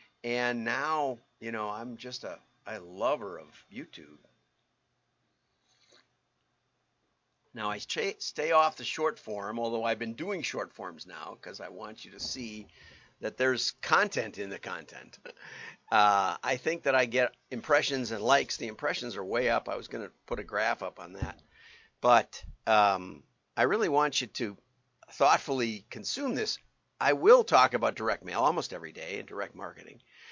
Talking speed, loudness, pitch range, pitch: 165 wpm, -30 LUFS, 115-150 Hz, 125 Hz